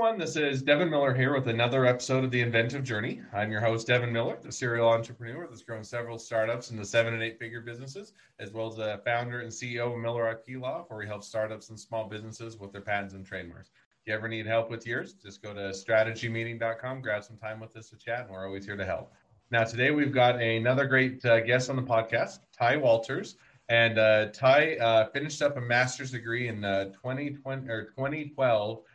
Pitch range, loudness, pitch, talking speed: 110-130 Hz, -28 LUFS, 115 Hz, 215 wpm